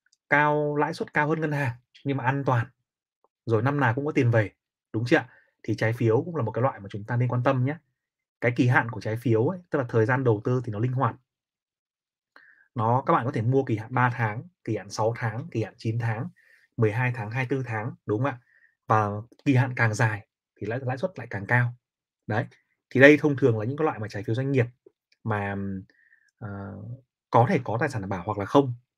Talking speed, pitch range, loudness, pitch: 240 wpm, 110-140 Hz, -25 LUFS, 125 Hz